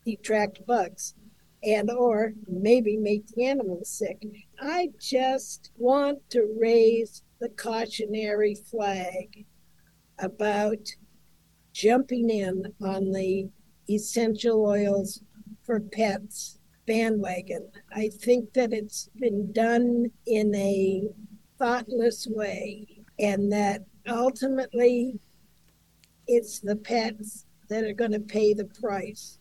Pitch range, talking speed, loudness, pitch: 205-235 Hz, 100 wpm, -27 LUFS, 215 Hz